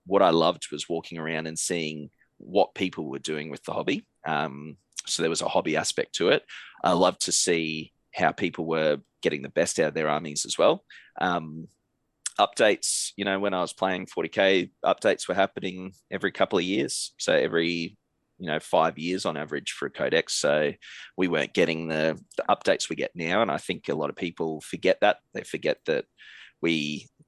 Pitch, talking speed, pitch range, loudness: 80 Hz, 200 wpm, 75-90 Hz, -26 LUFS